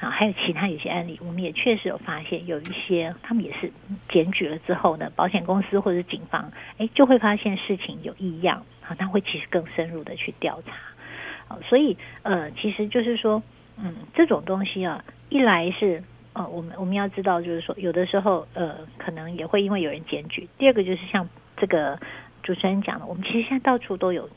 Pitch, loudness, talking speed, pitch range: 190 Hz, -24 LUFS, 315 characters per minute, 175-210 Hz